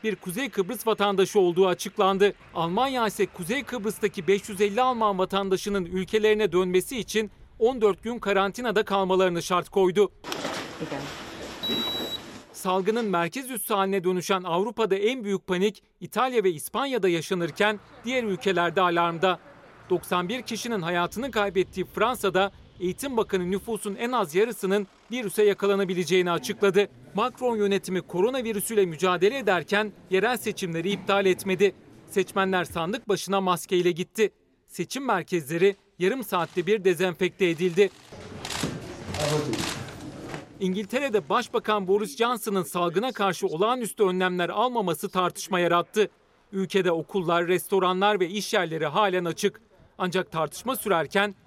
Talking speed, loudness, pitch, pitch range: 110 wpm, -26 LUFS, 195 Hz, 180-215 Hz